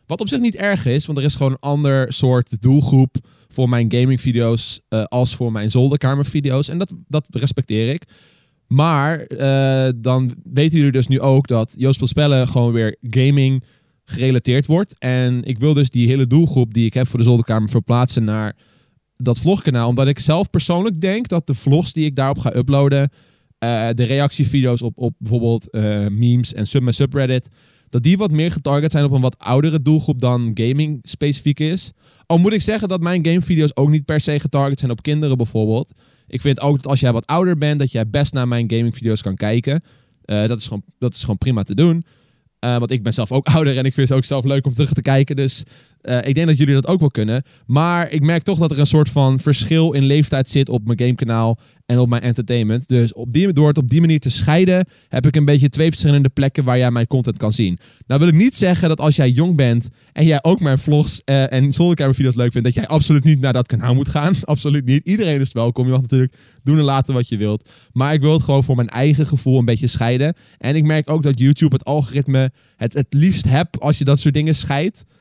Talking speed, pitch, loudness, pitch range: 230 wpm, 135 Hz, -17 LUFS, 125-150 Hz